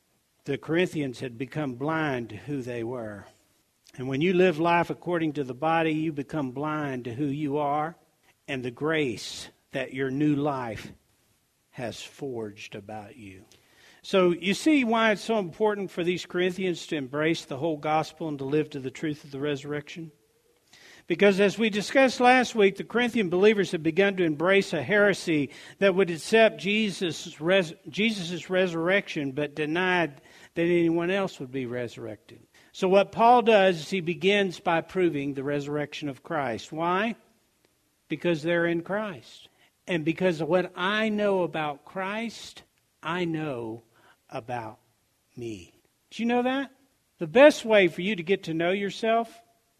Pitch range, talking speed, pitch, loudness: 145-195 Hz, 160 wpm, 165 Hz, -26 LUFS